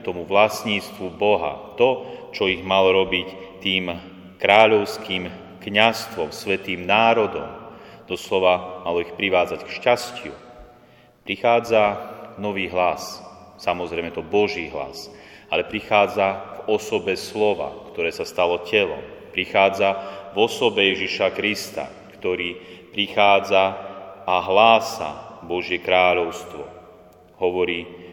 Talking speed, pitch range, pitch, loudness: 100 wpm, 90-110 Hz, 95 Hz, -21 LUFS